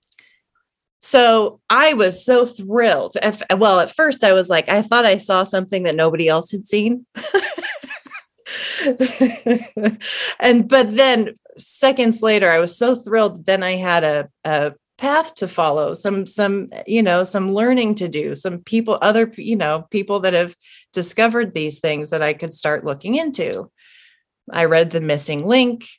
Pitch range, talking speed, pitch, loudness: 175-245 Hz, 155 wpm, 210 Hz, -17 LUFS